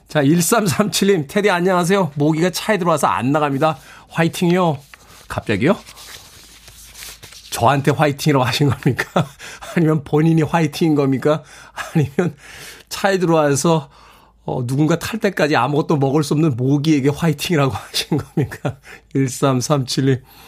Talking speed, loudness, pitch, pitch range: 295 characters per minute, -18 LUFS, 155 Hz, 145-170 Hz